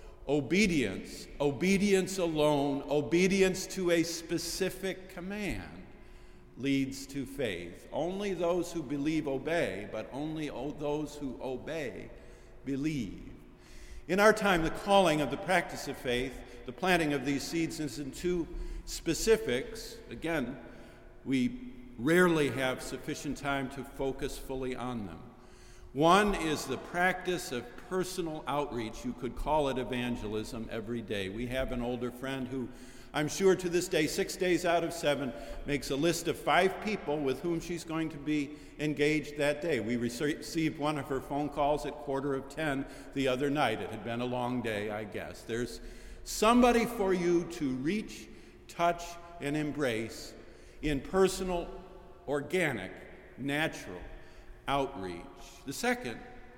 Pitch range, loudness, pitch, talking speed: 130-170 Hz, -32 LUFS, 145 Hz, 145 wpm